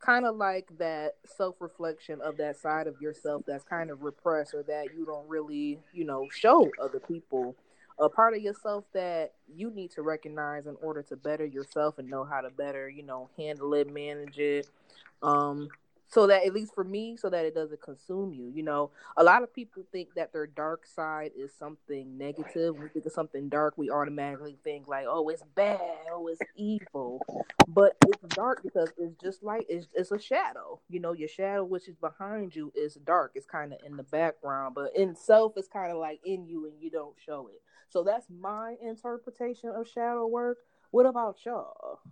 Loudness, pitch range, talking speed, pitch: -30 LUFS, 145-195 Hz, 205 wpm, 160 Hz